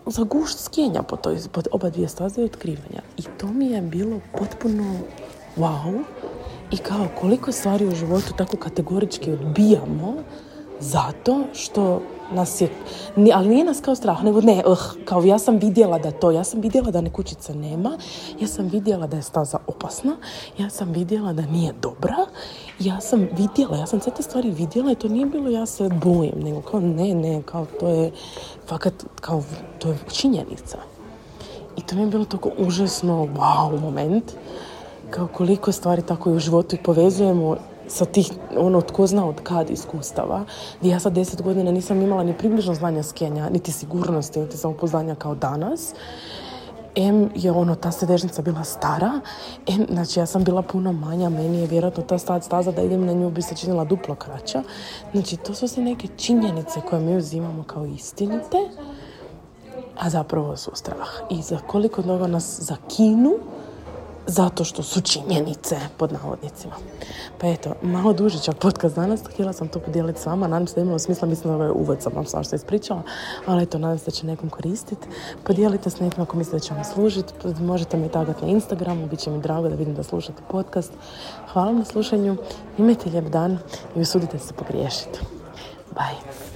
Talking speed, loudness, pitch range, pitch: 180 wpm, -22 LUFS, 165-205 Hz, 180 Hz